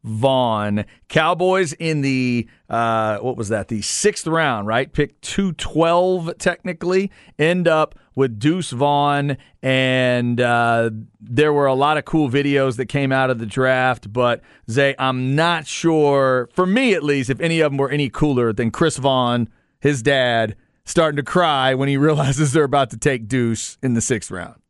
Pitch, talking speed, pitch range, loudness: 135 Hz, 175 wpm, 120-155 Hz, -19 LUFS